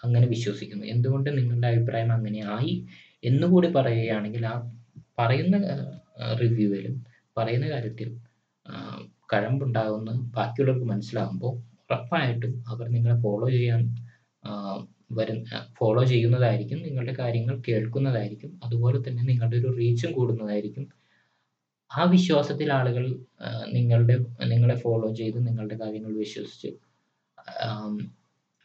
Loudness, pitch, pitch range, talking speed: -26 LUFS, 120 Hz, 110-125 Hz, 90 wpm